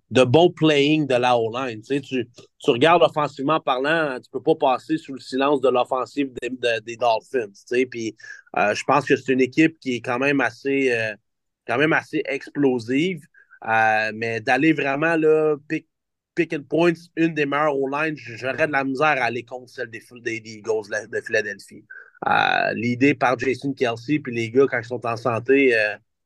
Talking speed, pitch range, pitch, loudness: 205 wpm, 120-155 Hz, 135 Hz, -21 LUFS